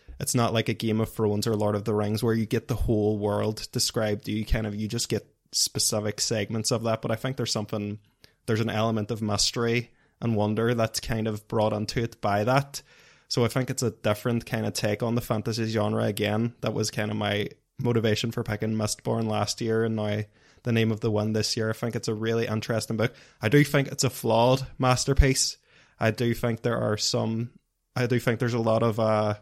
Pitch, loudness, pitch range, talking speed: 110 Hz, -26 LUFS, 105-120 Hz, 225 wpm